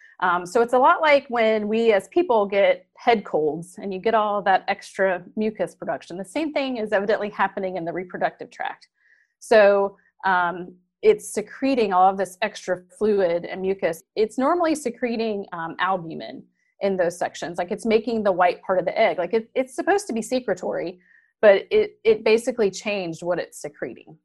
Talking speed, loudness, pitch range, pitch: 185 wpm, -22 LUFS, 185-245 Hz, 210 Hz